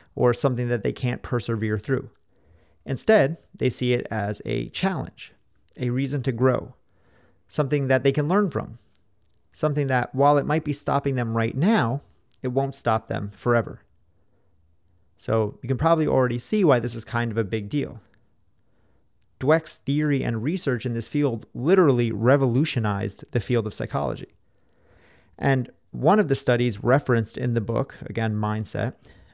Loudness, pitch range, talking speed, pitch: -24 LUFS, 110-140 Hz, 160 wpm, 120 Hz